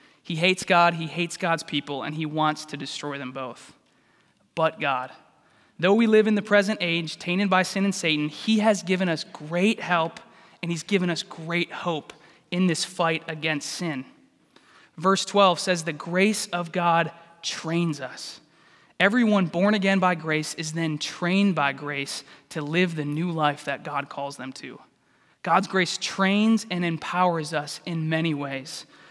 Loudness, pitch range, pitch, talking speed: -24 LUFS, 155-190 Hz, 170 Hz, 170 wpm